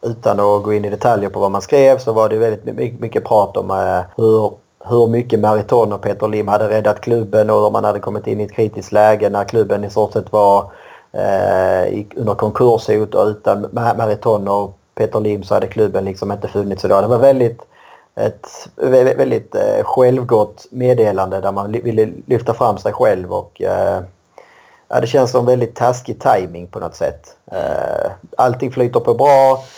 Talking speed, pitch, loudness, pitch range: 185 wpm, 110 Hz, -15 LUFS, 105-125 Hz